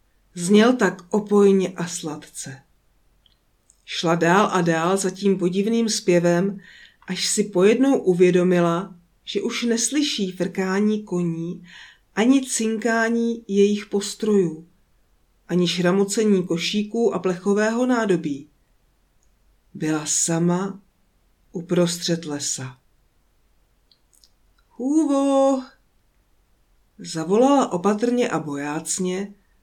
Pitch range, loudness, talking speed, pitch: 170-215 Hz, -21 LUFS, 85 wpm, 190 Hz